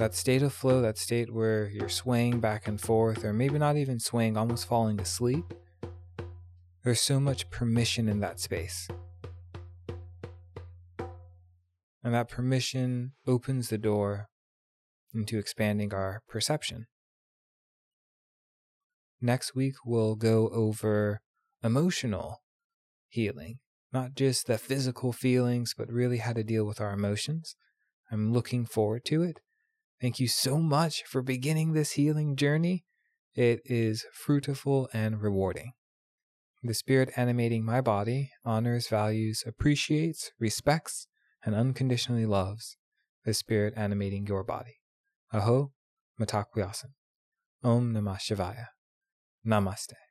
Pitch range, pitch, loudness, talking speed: 105-130 Hz, 115 Hz, -30 LUFS, 120 wpm